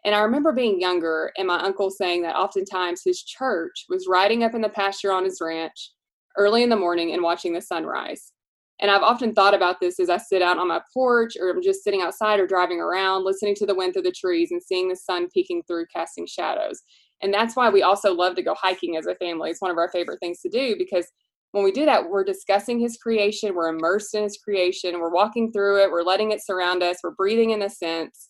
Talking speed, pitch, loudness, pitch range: 240 wpm, 195 Hz, -22 LUFS, 180-230 Hz